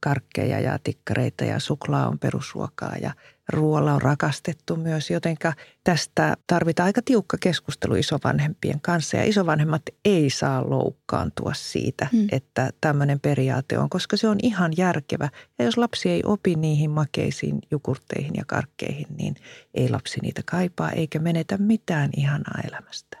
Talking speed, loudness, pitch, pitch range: 140 wpm, -24 LUFS, 160 Hz, 145-180 Hz